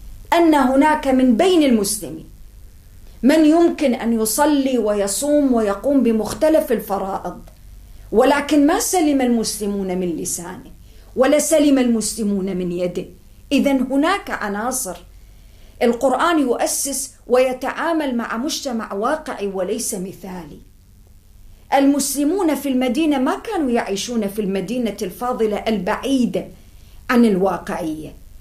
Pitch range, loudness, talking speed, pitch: 195-280 Hz, -18 LUFS, 100 wpm, 235 Hz